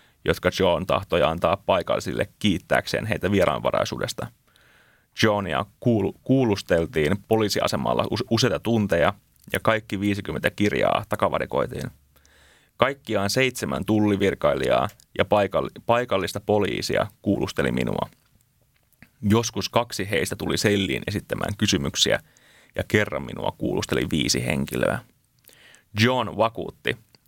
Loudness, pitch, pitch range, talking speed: -24 LUFS, 105 Hz, 90-115 Hz, 90 wpm